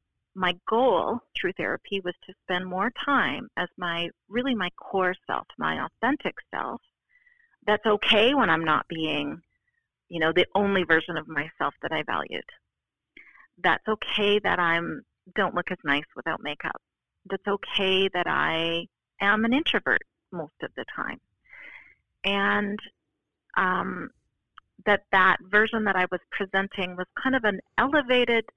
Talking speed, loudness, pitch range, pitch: 145 wpm, -26 LUFS, 180-215 Hz, 195 Hz